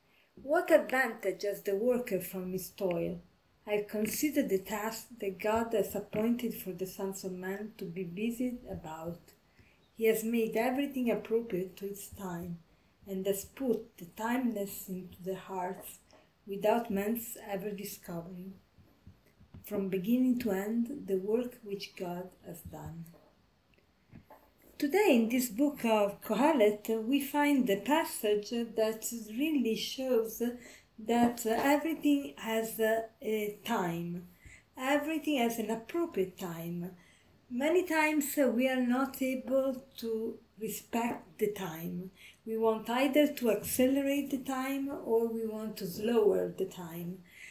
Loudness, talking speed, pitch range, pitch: -33 LUFS, 130 wpm, 195-245 Hz, 220 Hz